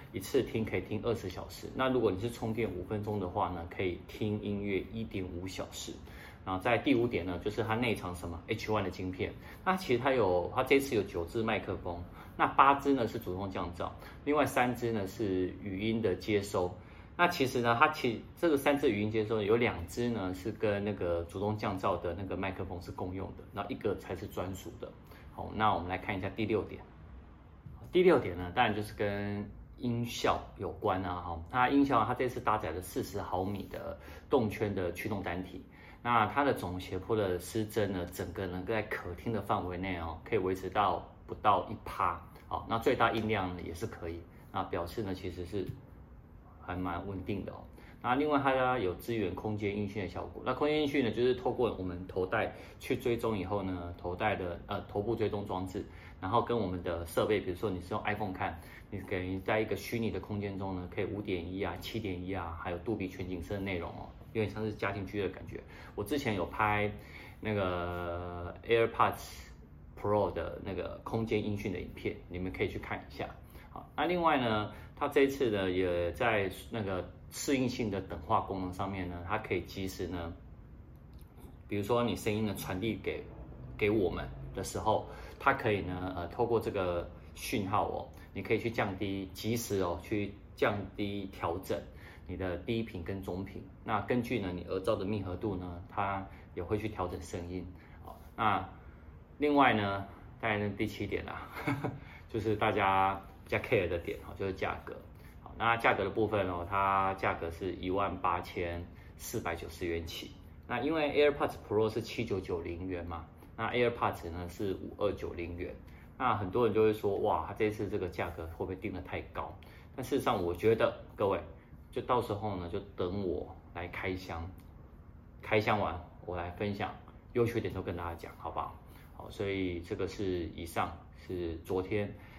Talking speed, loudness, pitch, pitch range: 285 characters per minute, -34 LUFS, 95 Hz, 90-110 Hz